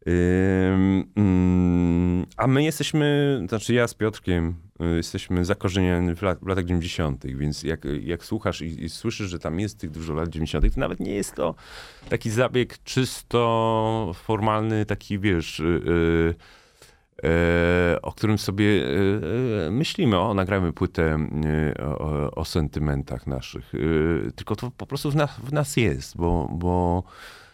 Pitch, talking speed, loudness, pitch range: 90 Hz, 145 wpm, -24 LUFS, 85-110 Hz